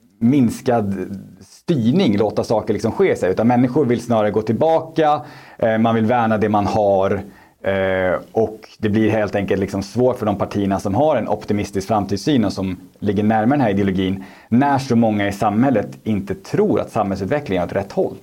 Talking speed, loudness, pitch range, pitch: 175 wpm, -18 LUFS, 100-120 Hz, 105 Hz